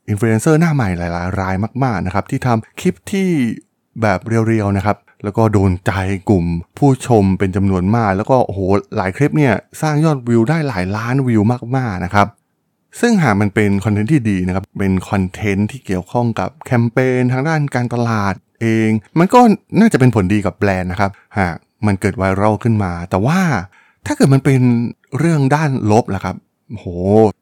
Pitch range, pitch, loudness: 100-130 Hz, 110 Hz, -16 LUFS